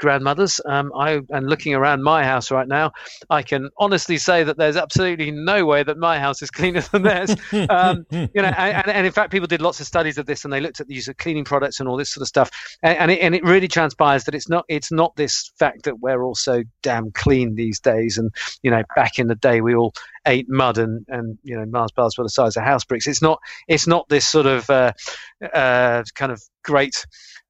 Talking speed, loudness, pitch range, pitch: 245 wpm, -19 LUFS, 125-165 Hz, 145 Hz